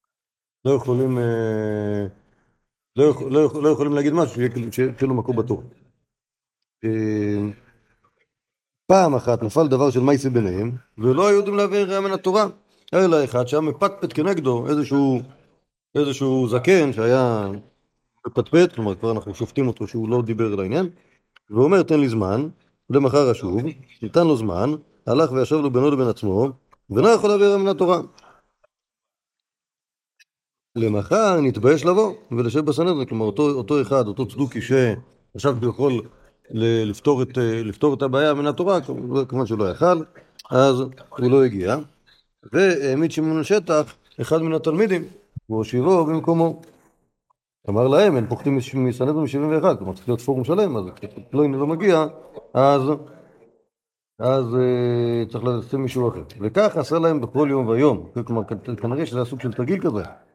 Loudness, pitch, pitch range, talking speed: -20 LUFS, 135 Hz, 120-155 Hz, 145 wpm